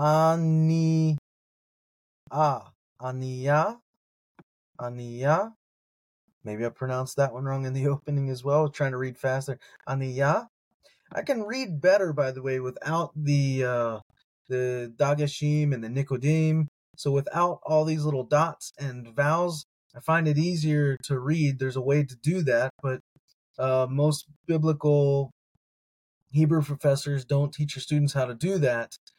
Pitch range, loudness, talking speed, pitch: 130-155 Hz, -26 LUFS, 140 wpm, 145 Hz